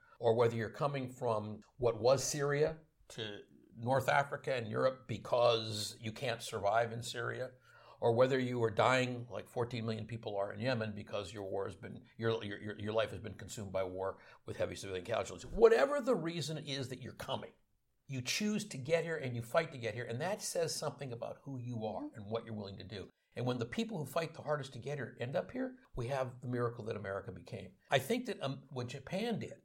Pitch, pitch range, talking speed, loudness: 120 Hz, 110-140 Hz, 220 wpm, -37 LUFS